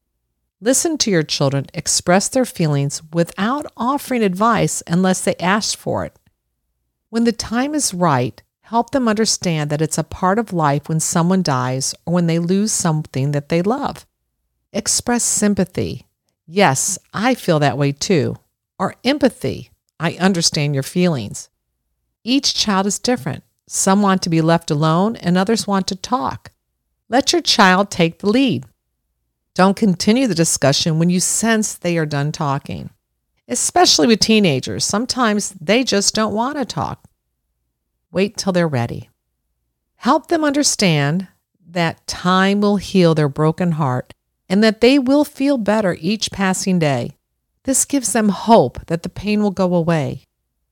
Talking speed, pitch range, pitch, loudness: 155 wpm, 145-220 Hz, 180 Hz, -17 LUFS